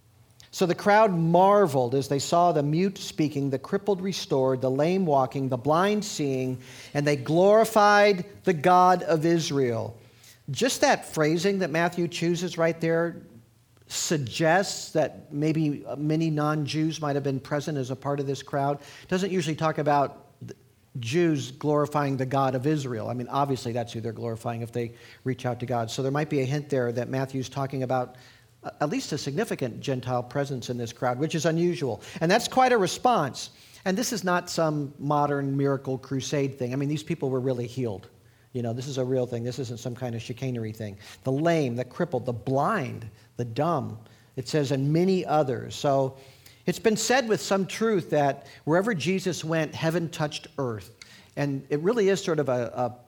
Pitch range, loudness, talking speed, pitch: 125-165 Hz, -26 LUFS, 190 wpm, 140 Hz